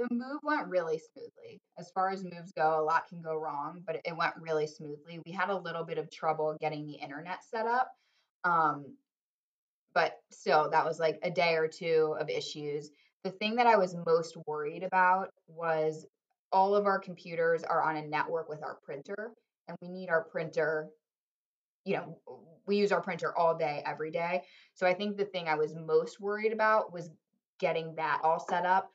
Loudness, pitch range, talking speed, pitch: -32 LUFS, 155-195 Hz, 195 wpm, 170 Hz